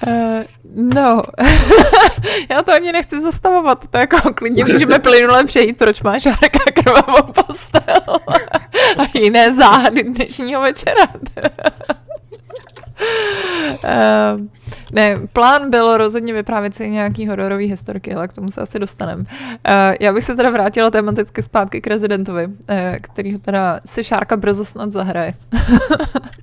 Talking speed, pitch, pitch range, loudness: 130 wpm, 235 Hz, 205-290 Hz, -13 LUFS